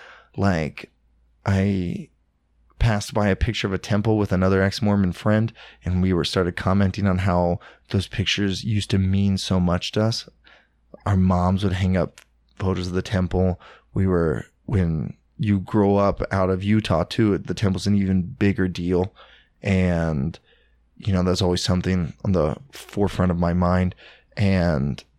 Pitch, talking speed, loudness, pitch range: 95 Hz, 160 wpm, -22 LUFS, 90-100 Hz